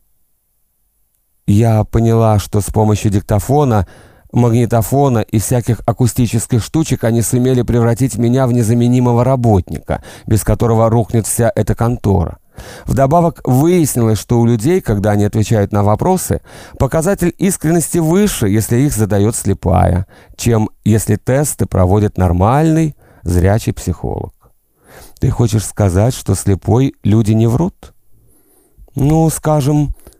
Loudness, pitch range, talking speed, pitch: -14 LUFS, 105-130 Hz, 115 wpm, 115 Hz